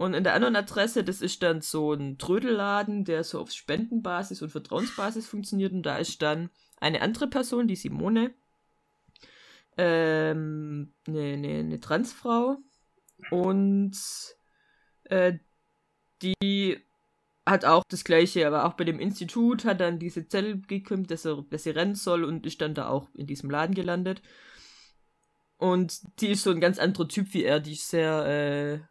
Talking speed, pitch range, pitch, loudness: 160 wpm, 155-205 Hz, 180 Hz, -28 LUFS